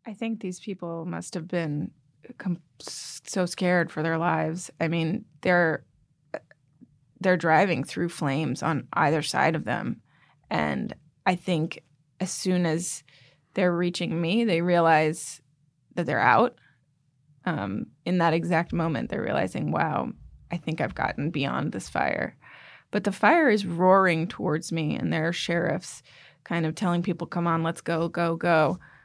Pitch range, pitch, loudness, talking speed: 155-180 Hz, 165 Hz, -26 LUFS, 155 wpm